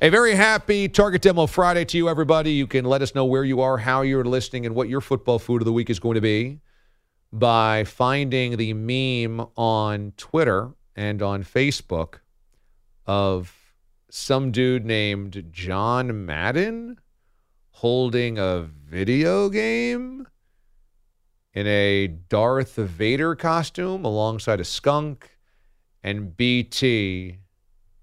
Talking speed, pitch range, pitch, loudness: 130 wpm, 100-135 Hz, 120 Hz, -22 LUFS